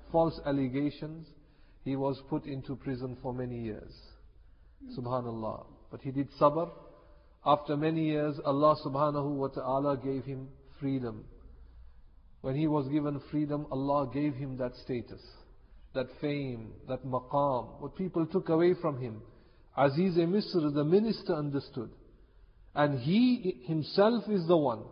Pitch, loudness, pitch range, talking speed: 140 Hz, -31 LUFS, 125-155 Hz, 140 wpm